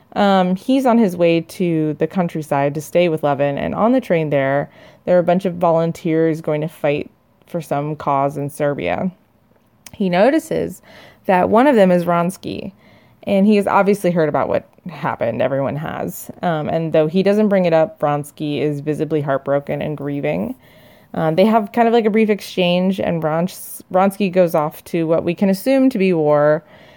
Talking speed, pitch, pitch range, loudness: 195 wpm, 170 Hz, 150-195 Hz, -17 LUFS